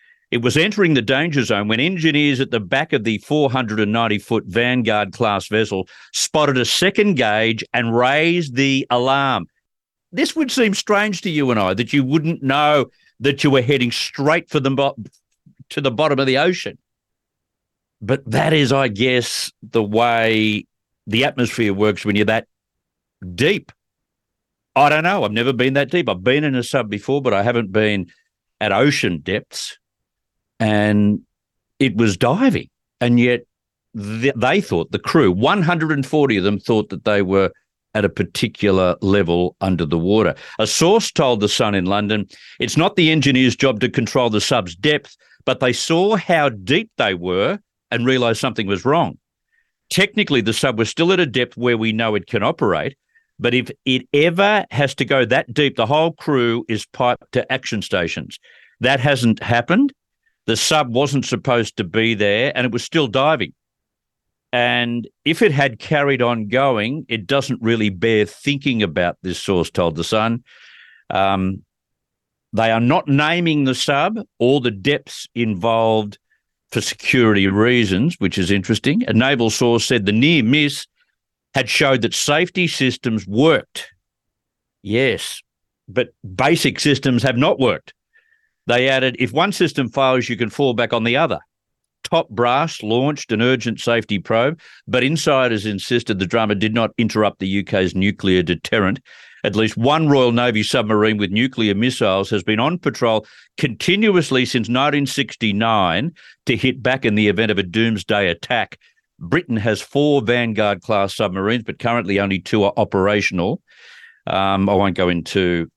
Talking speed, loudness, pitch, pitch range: 165 wpm, -18 LUFS, 120 Hz, 105-140 Hz